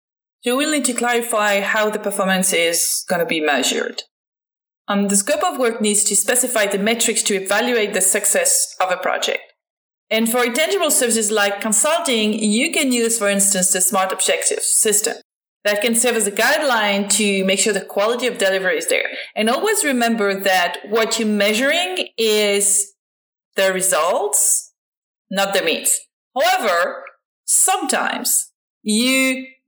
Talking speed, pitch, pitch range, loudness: 160 wpm, 220 Hz, 200-255 Hz, -17 LUFS